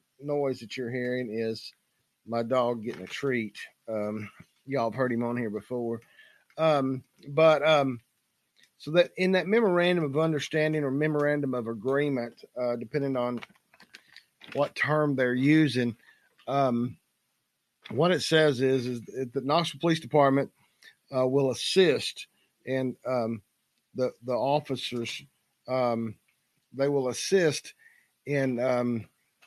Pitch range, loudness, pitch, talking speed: 120-145 Hz, -28 LUFS, 130 Hz, 130 wpm